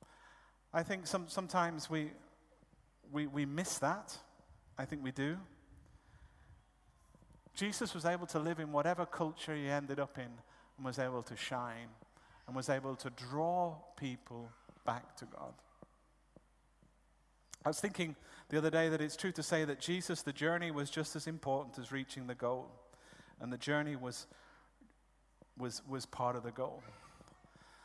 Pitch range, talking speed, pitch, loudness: 130-165 Hz, 155 wpm, 150 Hz, -40 LUFS